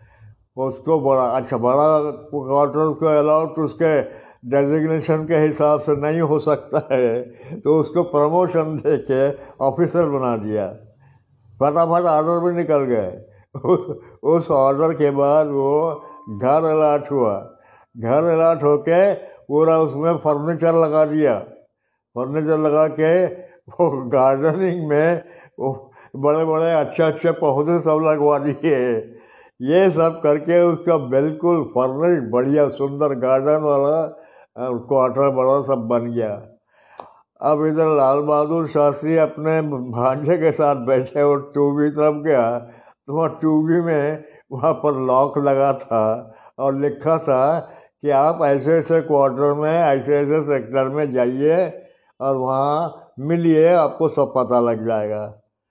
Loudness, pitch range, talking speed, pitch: -18 LUFS, 135-160 Hz, 130 wpm, 150 Hz